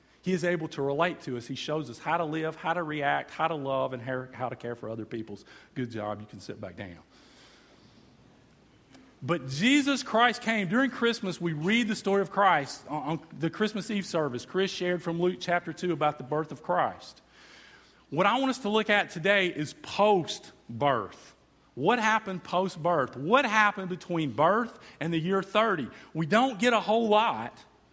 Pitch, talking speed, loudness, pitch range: 175 Hz, 195 wpm, -28 LUFS, 145-205 Hz